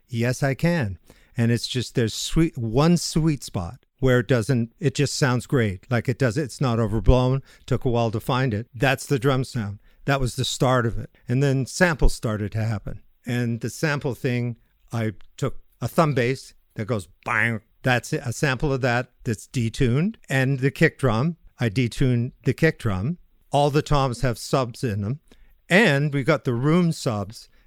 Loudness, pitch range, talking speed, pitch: -23 LUFS, 115-140 Hz, 190 wpm, 125 Hz